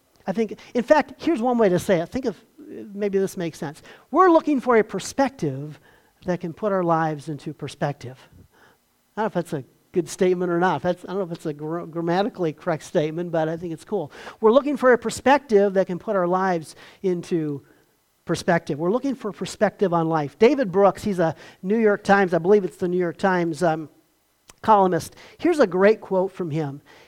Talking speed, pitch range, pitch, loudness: 210 wpm, 165-210 Hz, 185 Hz, -22 LUFS